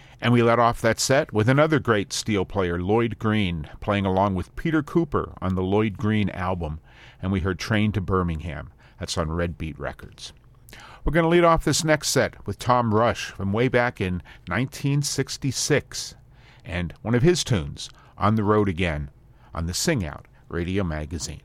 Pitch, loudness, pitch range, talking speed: 105 Hz, -23 LUFS, 90-125 Hz, 180 wpm